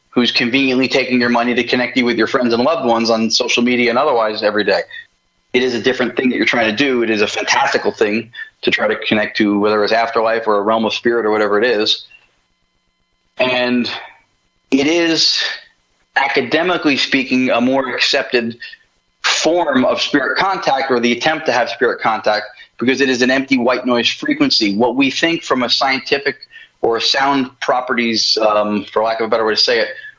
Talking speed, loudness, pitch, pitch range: 195 wpm, -15 LUFS, 125 Hz, 115-135 Hz